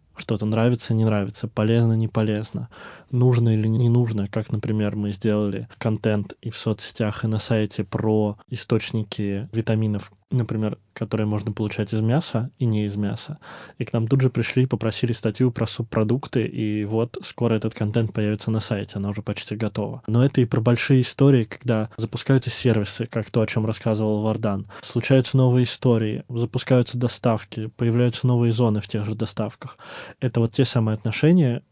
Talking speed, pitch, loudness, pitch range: 170 wpm, 115 Hz, -23 LUFS, 110-120 Hz